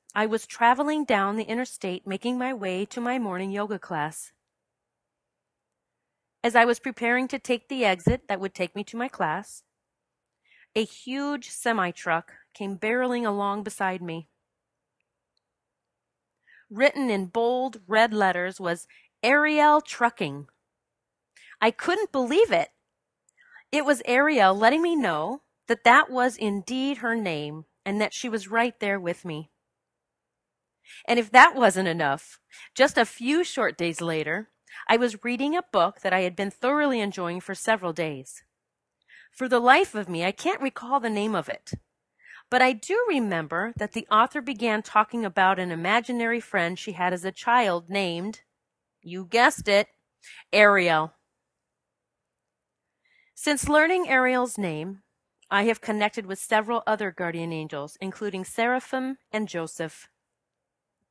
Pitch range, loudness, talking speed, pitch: 185-250 Hz, -24 LUFS, 145 wpm, 215 Hz